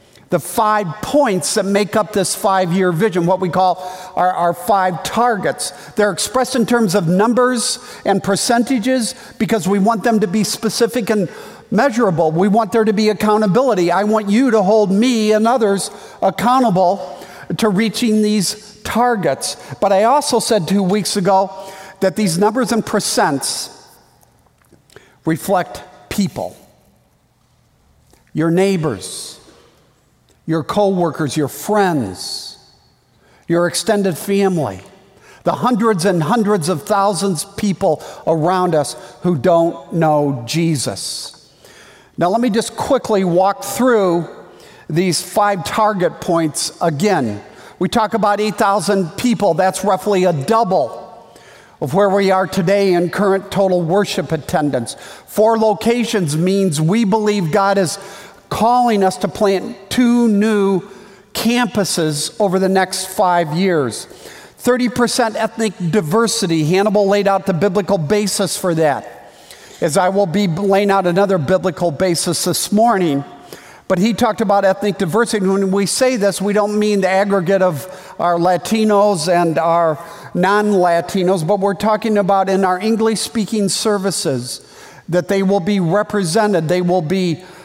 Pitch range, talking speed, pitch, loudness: 180-215 Hz, 140 wpm, 195 Hz, -16 LUFS